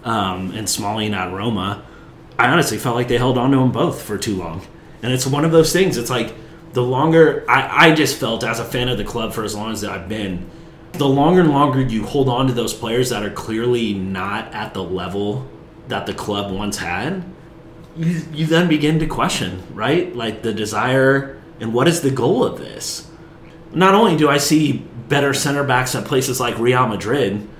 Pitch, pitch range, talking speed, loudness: 125 Hz, 105-150 Hz, 210 wpm, -18 LUFS